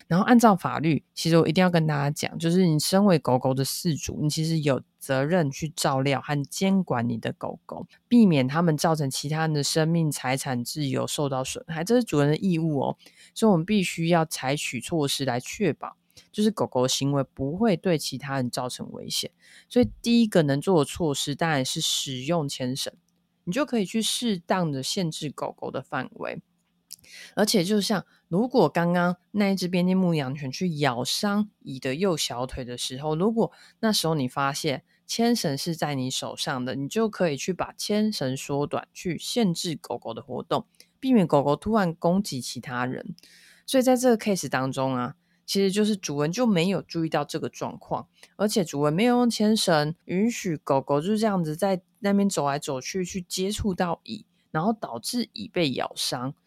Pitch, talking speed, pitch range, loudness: 165 Hz, 285 characters per minute, 140-200 Hz, -25 LUFS